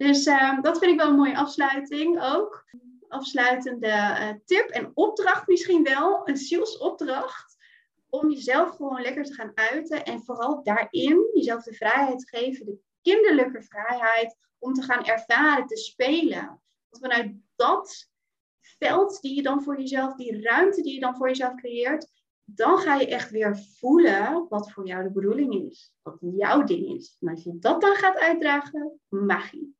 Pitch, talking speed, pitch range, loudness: 275 Hz, 170 wpm, 235-335 Hz, -24 LUFS